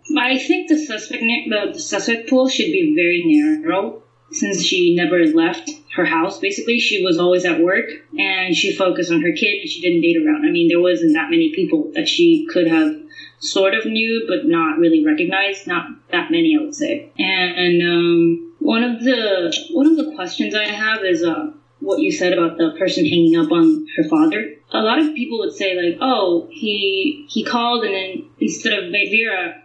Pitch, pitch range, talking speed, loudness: 300 Hz, 195-325 Hz, 200 wpm, -17 LUFS